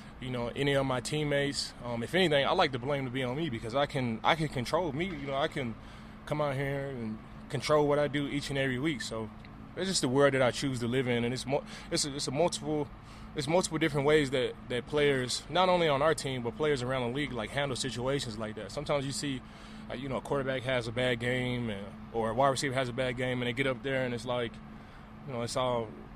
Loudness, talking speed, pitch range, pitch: -31 LUFS, 255 wpm, 120-145 Hz, 135 Hz